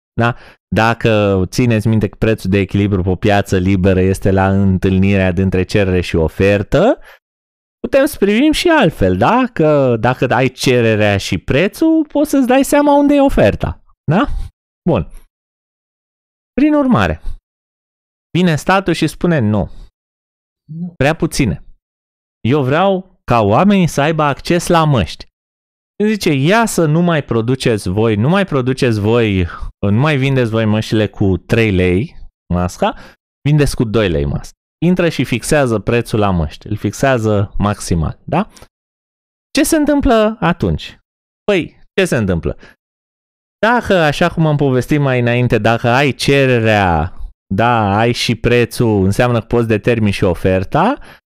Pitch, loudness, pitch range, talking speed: 120 Hz, -14 LUFS, 100-155 Hz, 140 wpm